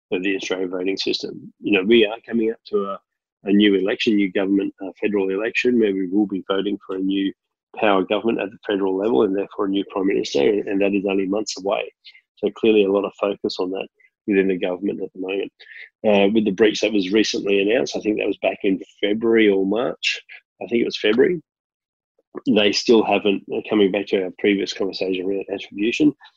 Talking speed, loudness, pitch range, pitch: 215 wpm, -20 LUFS, 95-110 Hz, 100 Hz